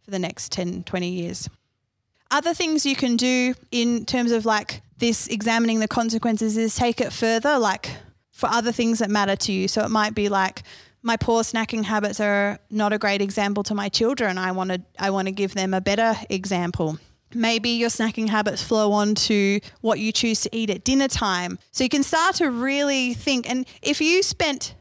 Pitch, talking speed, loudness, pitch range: 220 Hz, 205 wpm, -22 LUFS, 200-240 Hz